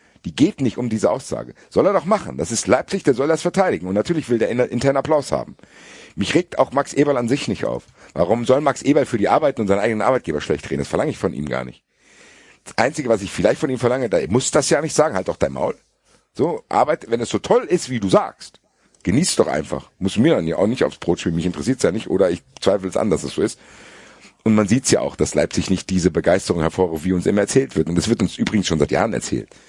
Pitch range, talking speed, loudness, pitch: 90-140 Hz, 270 wpm, -19 LUFS, 115 Hz